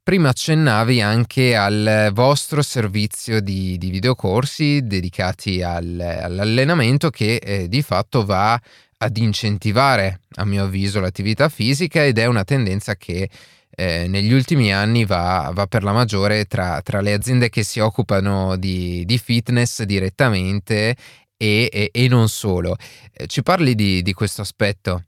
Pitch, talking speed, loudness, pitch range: 105 Hz, 145 wpm, -18 LUFS, 95-125 Hz